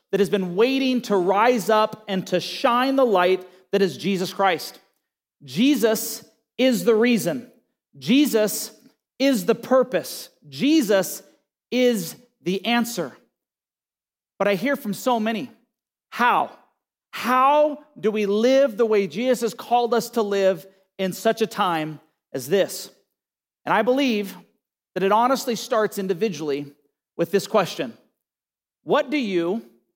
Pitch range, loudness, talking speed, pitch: 190-245 Hz, -22 LUFS, 135 wpm, 215 Hz